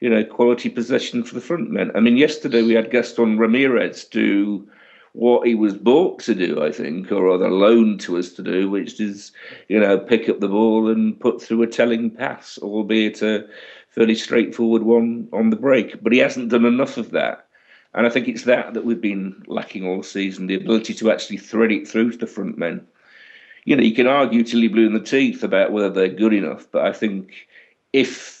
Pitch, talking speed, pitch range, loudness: 110 Hz, 215 wpm, 105-115 Hz, -19 LUFS